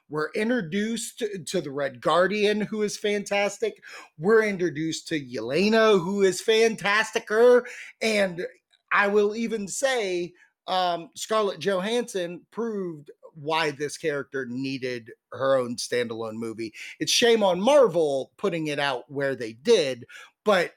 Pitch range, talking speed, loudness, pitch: 155-220 Hz, 125 wpm, -25 LUFS, 195 Hz